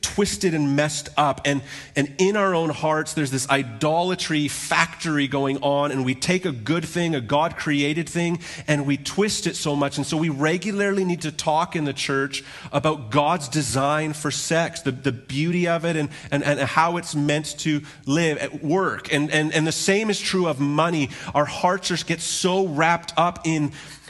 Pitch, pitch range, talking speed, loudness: 155 Hz, 145-170 Hz, 195 wpm, -22 LUFS